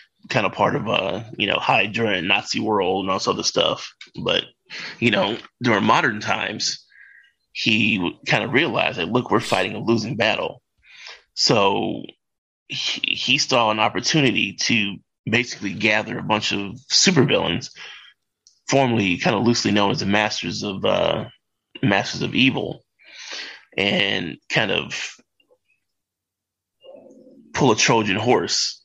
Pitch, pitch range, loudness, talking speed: 105 Hz, 100-120 Hz, -20 LUFS, 140 wpm